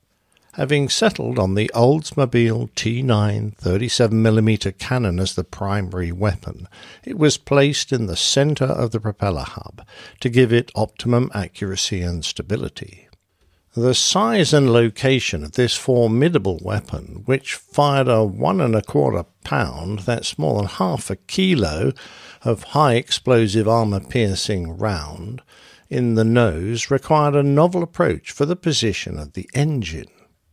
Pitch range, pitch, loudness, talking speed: 95-130 Hz, 115 Hz, -19 LUFS, 135 wpm